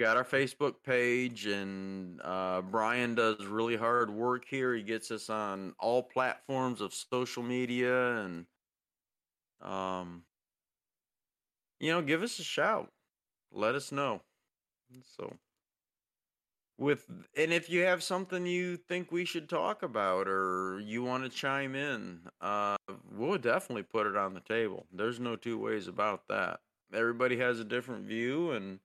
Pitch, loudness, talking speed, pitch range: 120 Hz, -33 LUFS, 150 wpm, 105-135 Hz